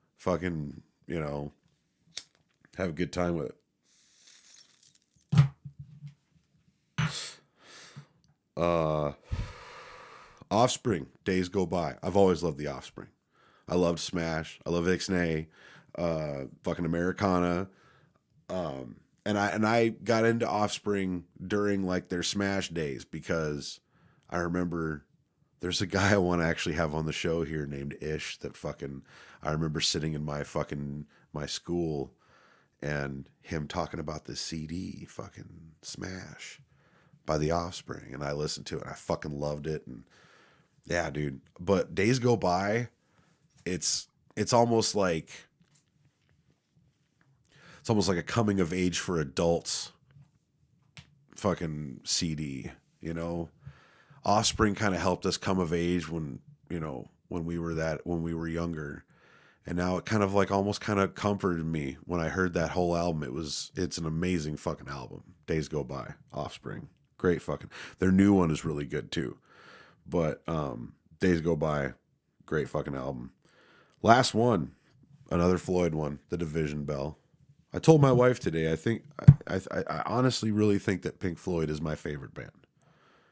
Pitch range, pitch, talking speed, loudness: 80-100 Hz, 85 Hz, 150 wpm, -30 LUFS